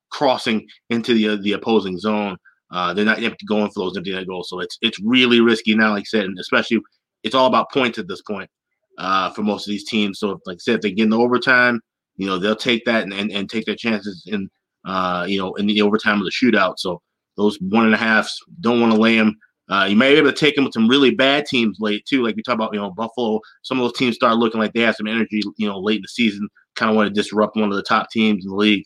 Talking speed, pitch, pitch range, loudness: 275 wpm, 110 Hz, 105-115 Hz, -18 LUFS